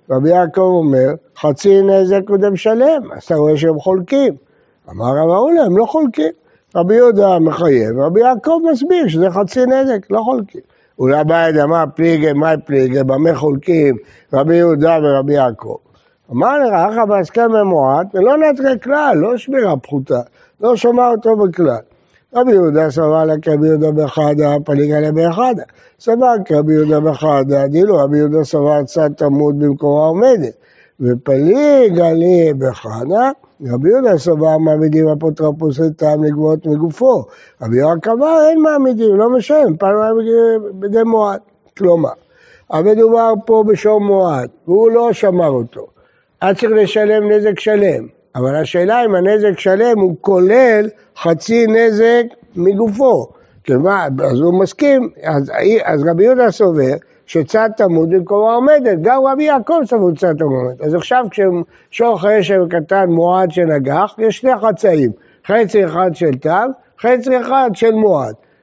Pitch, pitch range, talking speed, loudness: 190 Hz, 155-230 Hz, 145 wpm, -13 LUFS